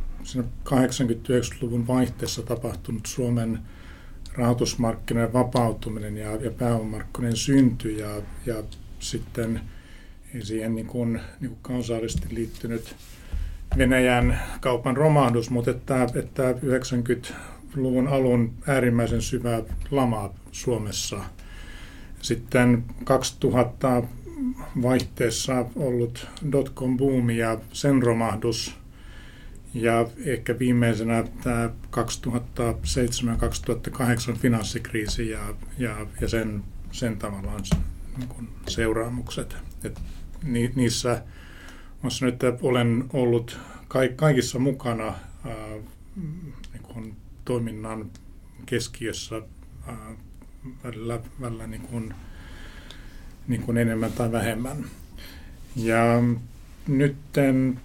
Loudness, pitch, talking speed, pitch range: -26 LUFS, 115 Hz, 80 wpm, 110-125 Hz